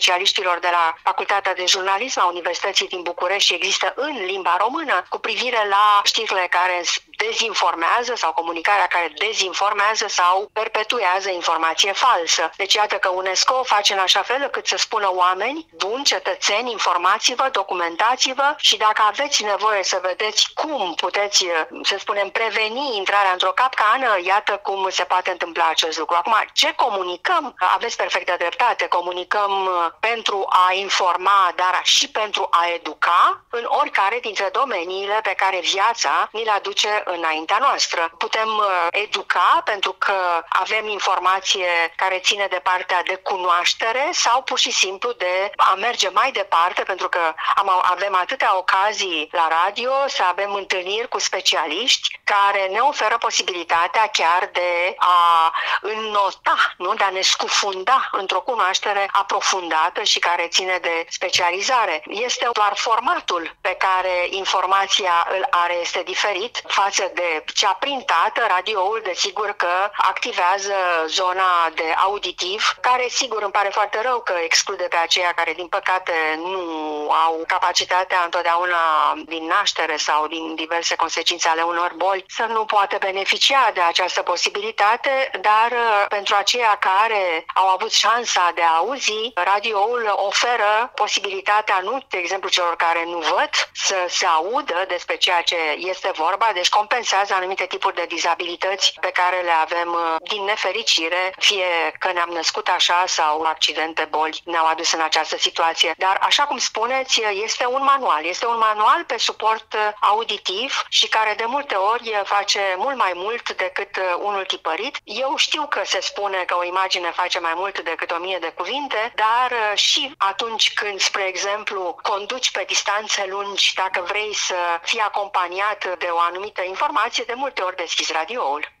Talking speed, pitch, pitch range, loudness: 150 wpm, 195 Hz, 175-215 Hz, -19 LUFS